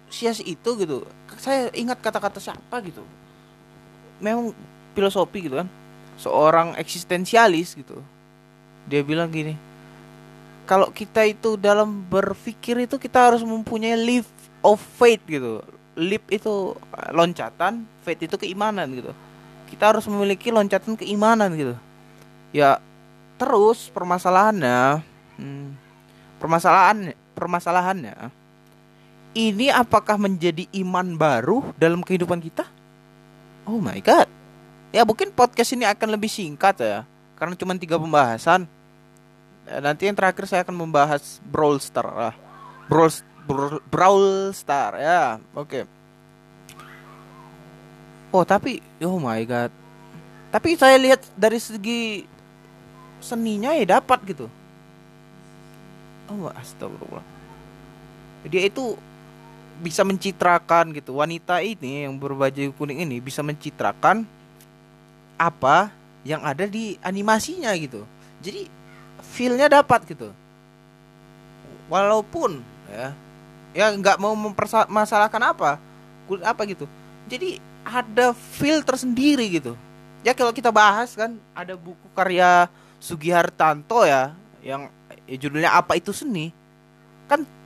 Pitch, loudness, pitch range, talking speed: 180 Hz, -21 LUFS, 140-220 Hz, 110 wpm